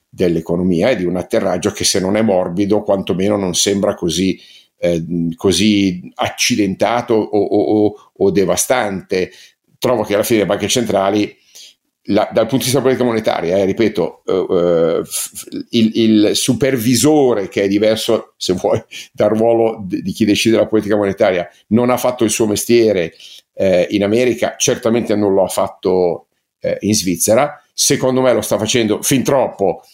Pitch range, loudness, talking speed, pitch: 95-115 Hz, -15 LUFS, 165 wpm, 105 Hz